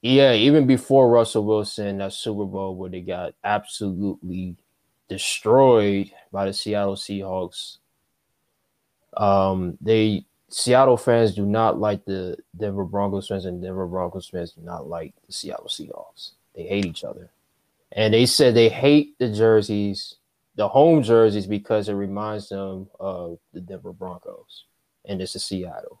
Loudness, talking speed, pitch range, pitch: -21 LUFS, 150 wpm, 95-110 Hz, 100 Hz